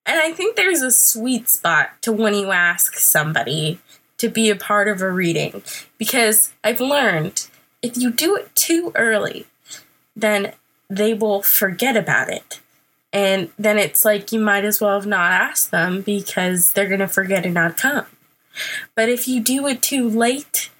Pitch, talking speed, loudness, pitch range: 215 Hz, 175 wpm, -17 LUFS, 195-245 Hz